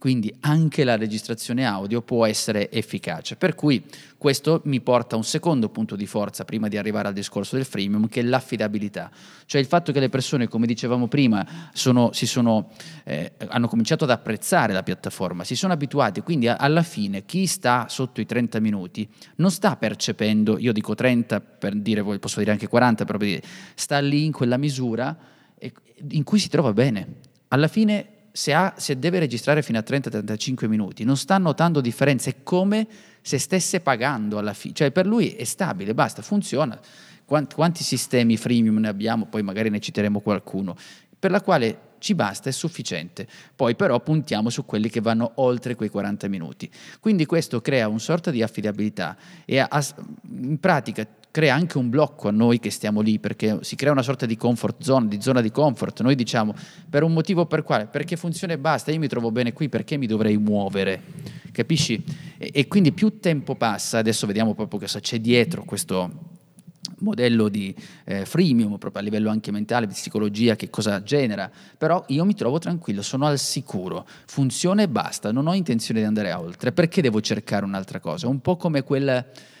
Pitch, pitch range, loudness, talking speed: 125 Hz, 110-160 Hz, -23 LUFS, 185 wpm